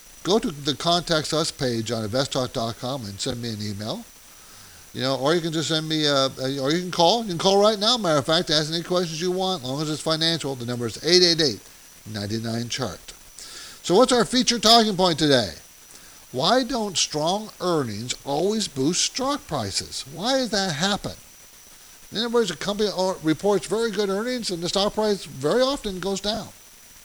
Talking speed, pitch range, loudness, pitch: 205 wpm, 130-200 Hz, -22 LUFS, 160 Hz